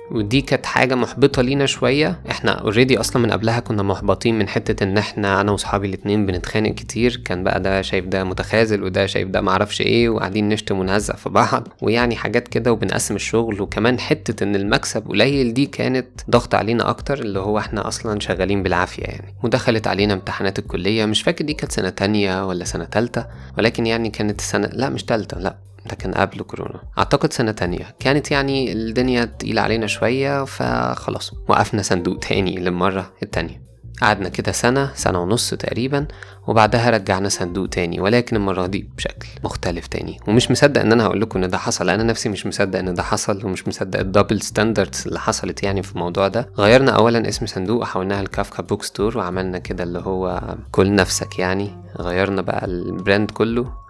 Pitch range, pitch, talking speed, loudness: 95-115 Hz, 105 Hz, 180 wpm, -19 LUFS